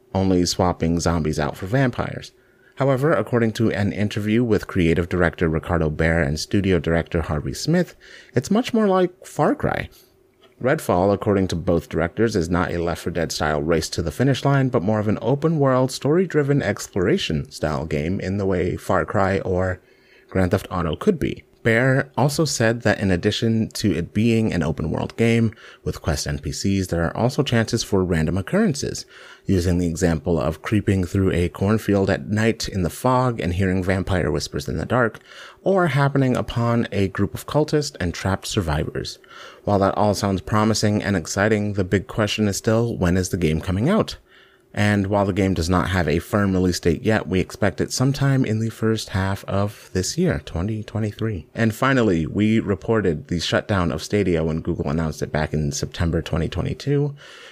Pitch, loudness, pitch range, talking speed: 100 Hz, -21 LUFS, 85-115 Hz, 185 wpm